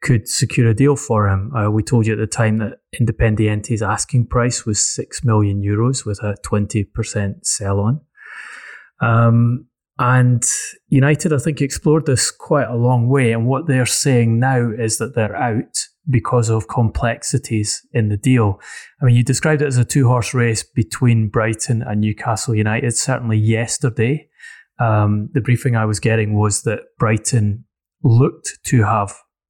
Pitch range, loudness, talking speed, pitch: 110-125 Hz, -17 LUFS, 165 wpm, 115 Hz